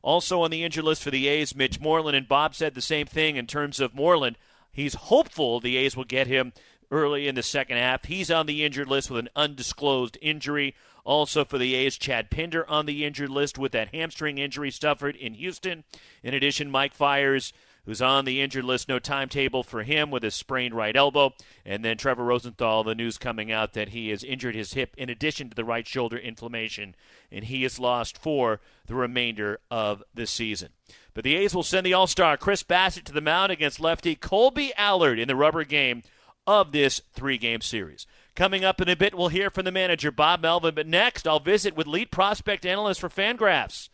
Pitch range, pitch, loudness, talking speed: 125-160 Hz, 140 Hz, -25 LUFS, 210 wpm